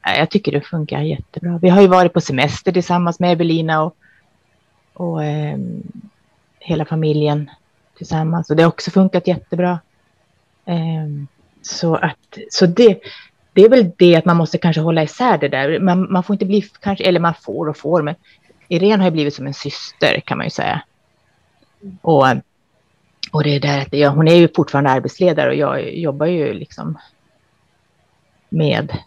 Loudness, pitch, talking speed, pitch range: -16 LUFS, 170 Hz, 175 wpm, 150-185 Hz